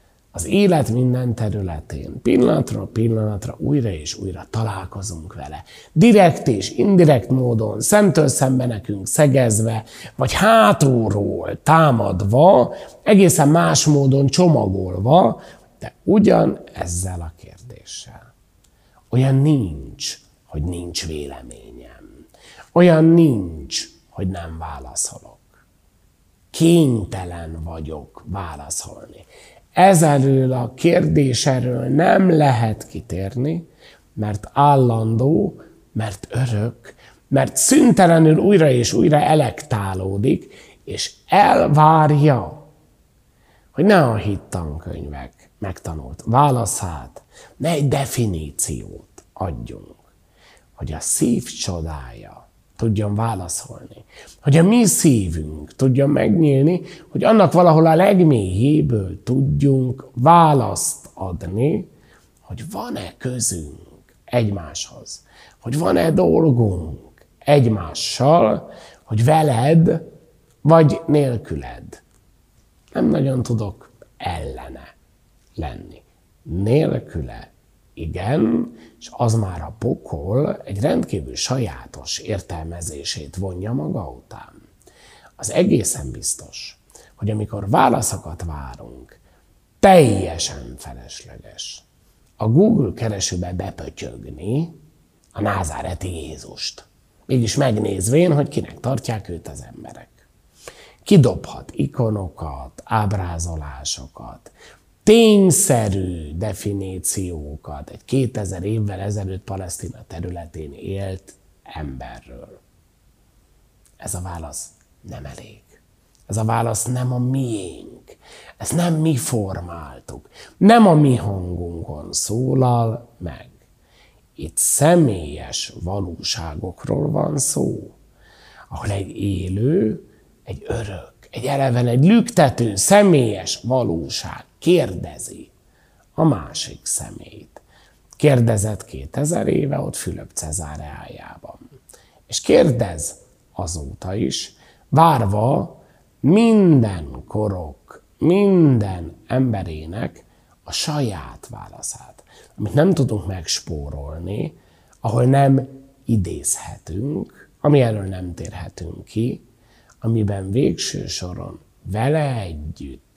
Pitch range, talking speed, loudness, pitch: 90-140 Hz, 90 wpm, -18 LUFS, 110 Hz